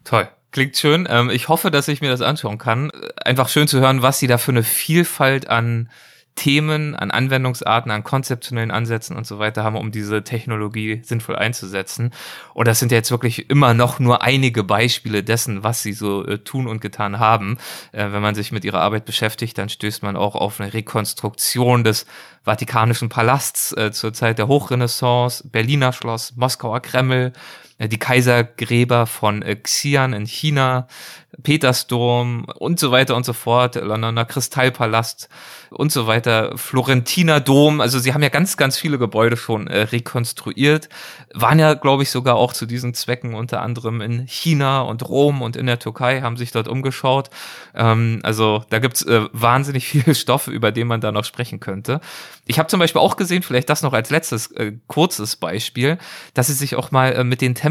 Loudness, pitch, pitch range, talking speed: -18 LUFS, 120 Hz, 110-135 Hz, 185 wpm